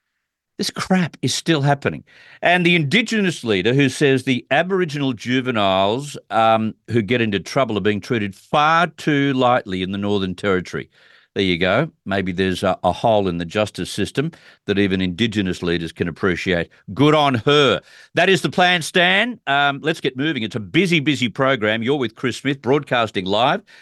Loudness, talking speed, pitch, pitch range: -19 LUFS, 175 wpm, 130 Hz, 100-155 Hz